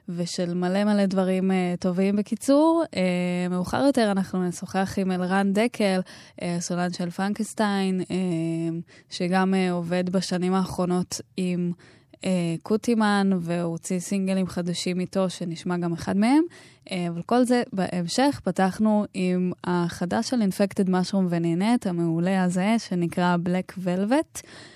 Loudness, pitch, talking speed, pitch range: -25 LUFS, 185 Hz, 125 wpm, 180-200 Hz